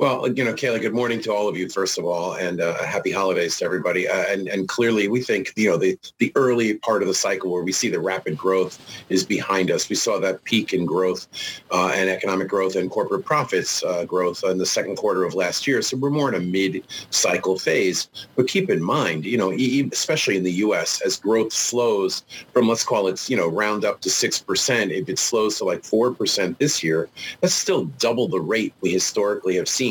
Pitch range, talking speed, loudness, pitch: 90-115 Hz, 230 wpm, -21 LUFS, 95 Hz